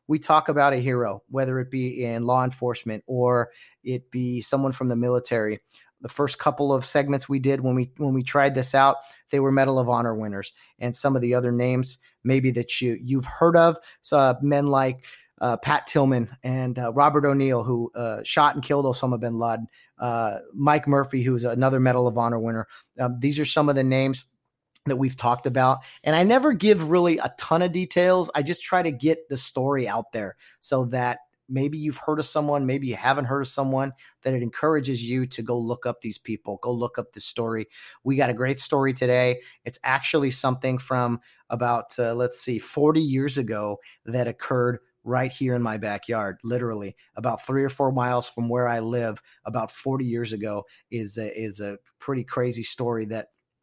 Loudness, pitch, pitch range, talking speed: -24 LUFS, 130 Hz, 120-140 Hz, 200 wpm